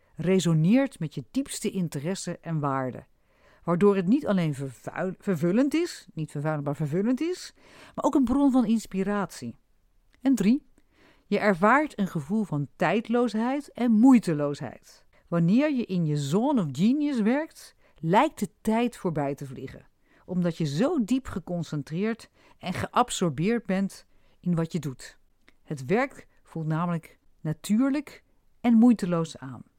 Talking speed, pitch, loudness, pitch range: 140 wpm, 195 Hz, -26 LUFS, 160-245 Hz